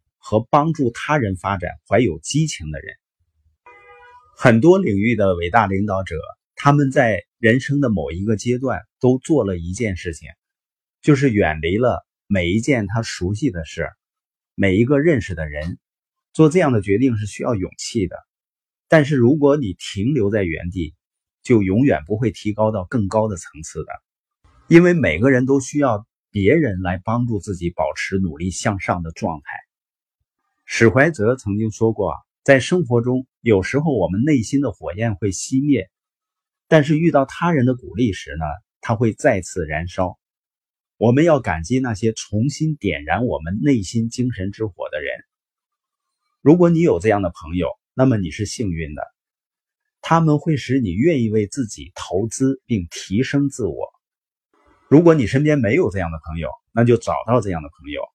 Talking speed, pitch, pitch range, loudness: 245 characters per minute, 115 Hz, 95-140 Hz, -19 LUFS